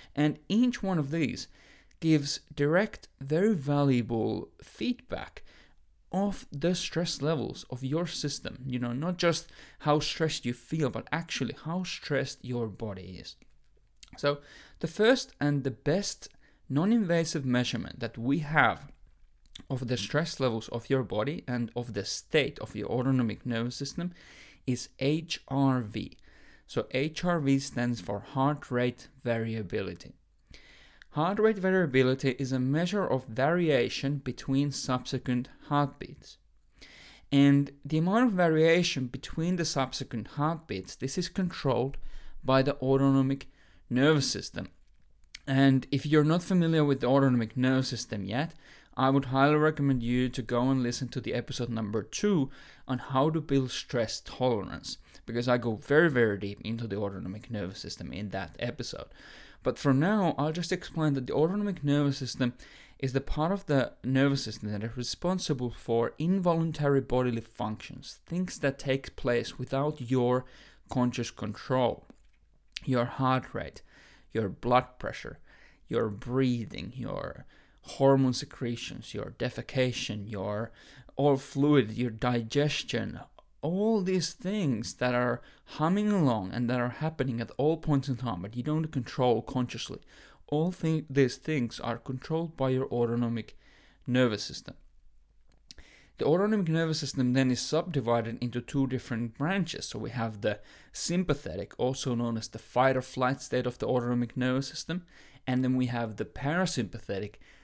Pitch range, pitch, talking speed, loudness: 120-150 Hz, 135 Hz, 145 wpm, -30 LUFS